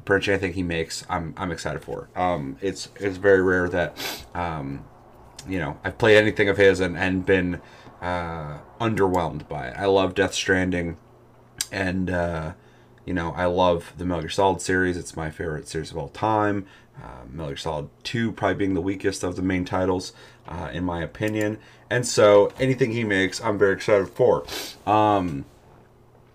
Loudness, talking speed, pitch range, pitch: -23 LUFS, 175 wpm, 85-100 Hz, 95 Hz